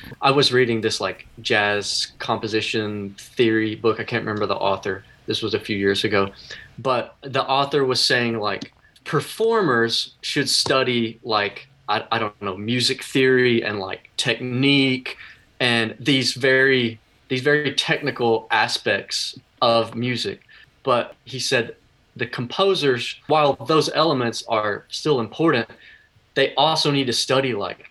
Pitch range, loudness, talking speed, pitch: 110-135 Hz, -21 LUFS, 140 wpm, 120 Hz